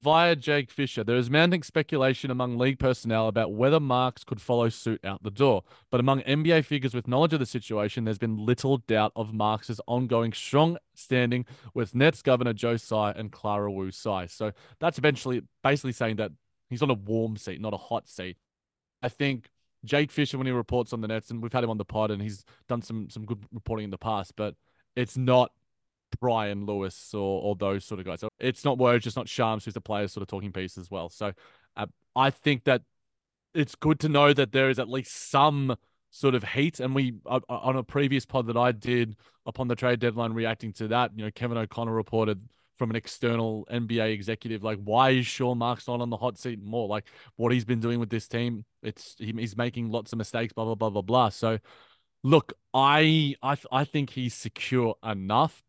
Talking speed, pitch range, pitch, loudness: 215 wpm, 110-130 Hz, 120 Hz, -27 LUFS